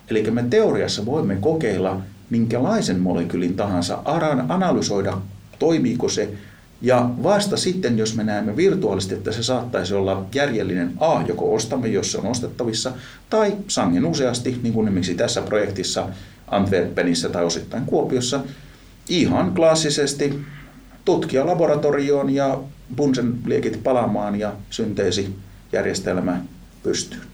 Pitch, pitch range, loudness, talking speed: 115 Hz, 95-140 Hz, -21 LUFS, 115 wpm